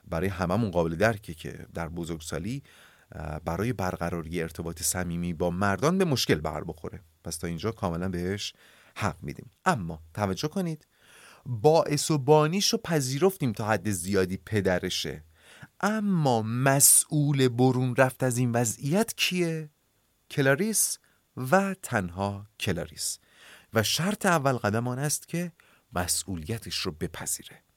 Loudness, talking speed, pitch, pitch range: -27 LUFS, 125 wpm, 115 Hz, 90-145 Hz